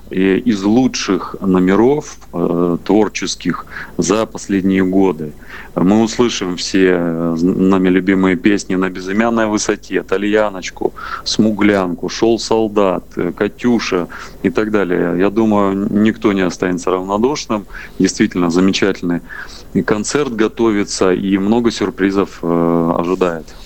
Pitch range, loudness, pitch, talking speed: 90-105 Hz, -15 LUFS, 95 Hz, 100 wpm